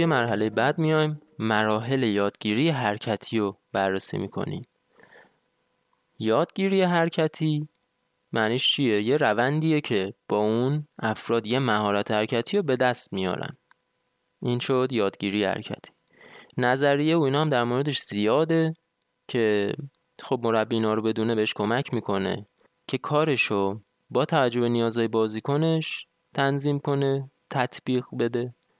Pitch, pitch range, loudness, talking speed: 125 Hz, 110-145 Hz, -25 LUFS, 120 wpm